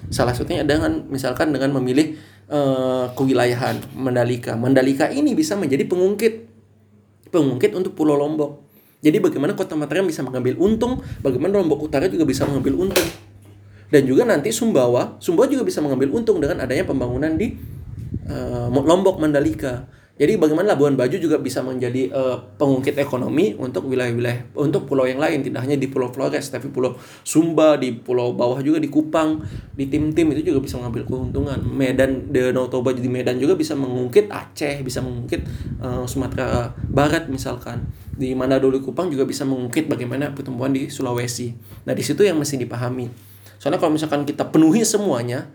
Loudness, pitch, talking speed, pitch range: -20 LUFS, 130 Hz, 160 wpm, 125-150 Hz